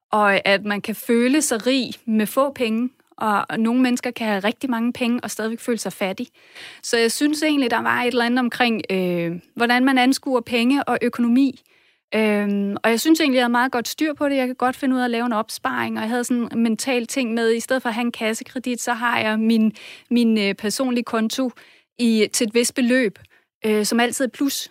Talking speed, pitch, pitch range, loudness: 230 wpm, 240 Hz, 220-255 Hz, -20 LUFS